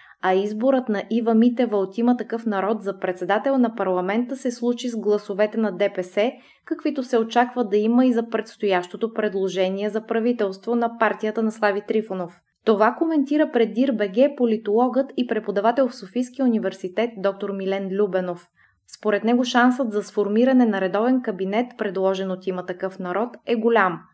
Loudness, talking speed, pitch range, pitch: -22 LUFS, 155 wpm, 195-240 Hz, 220 Hz